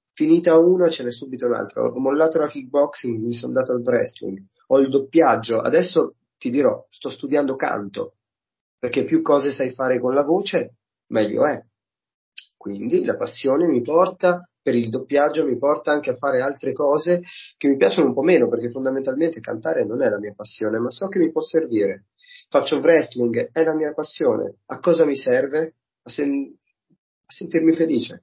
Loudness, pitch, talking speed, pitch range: -20 LUFS, 150 Hz, 180 wpm, 130-165 Hz